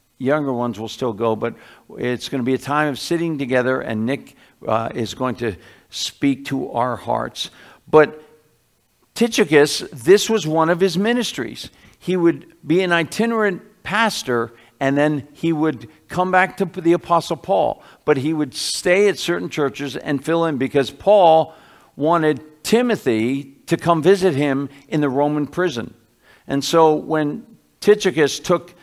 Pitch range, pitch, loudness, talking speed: 135-175 Hz, 155 Hz, -19 LUFS, 160 wpm